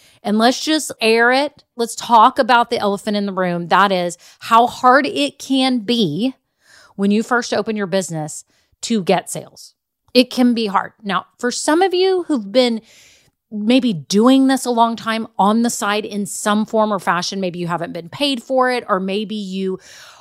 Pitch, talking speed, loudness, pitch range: 225 Hz, 190 wpm, -17 LUFS, 200-250 Hz